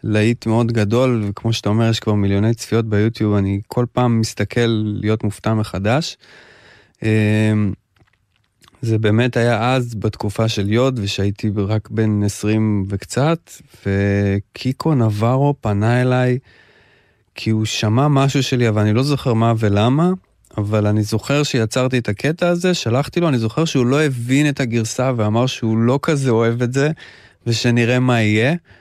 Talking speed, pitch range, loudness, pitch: 150 wpm, 105-130 Hz, -18 LUFS, 115 Hz